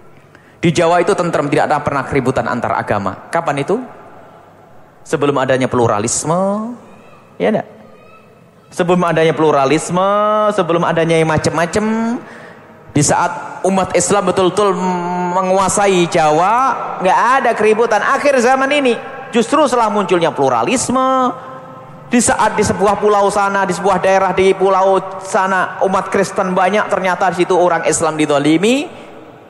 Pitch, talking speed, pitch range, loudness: 190 Hz, 125 wpm, 165-210 Hz, -14 LUFS